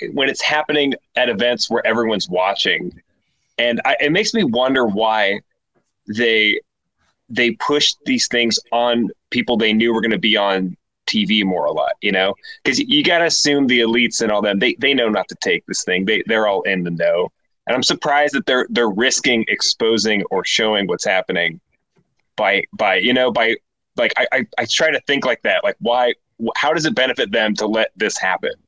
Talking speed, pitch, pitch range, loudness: 200 wpm, 120 Hz, 110-150 Hz, -17 LUFS